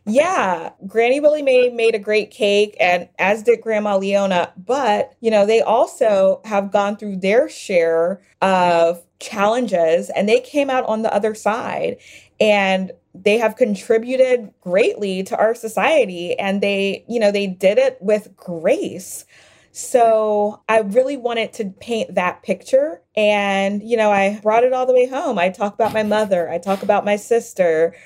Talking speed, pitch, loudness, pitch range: 165 wpm, 210 Hz, -18 LUFS, 195-235 Hz